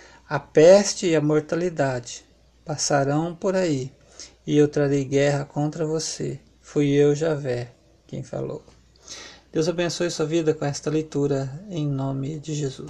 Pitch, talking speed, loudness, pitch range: 150 Hz, 140 wpm, -23 LUFS, 140-160 Hz